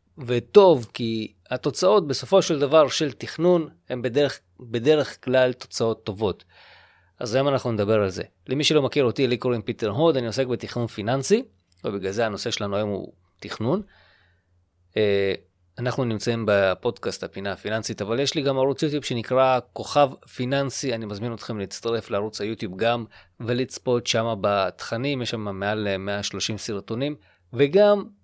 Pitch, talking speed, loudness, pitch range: 120 Hz, 145 wpm, -24 LUFS, 105-135 Hz